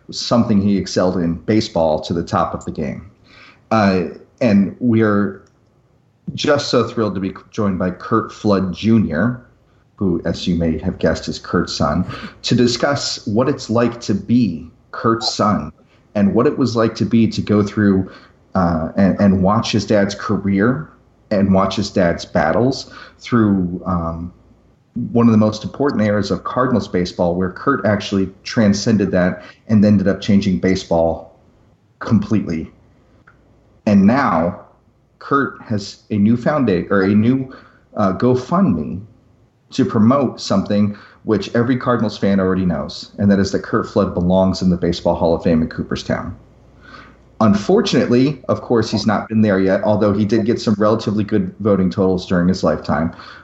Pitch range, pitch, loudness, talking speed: 95-115 Hz, 105 Hz, -17 LUFS, 160 wpm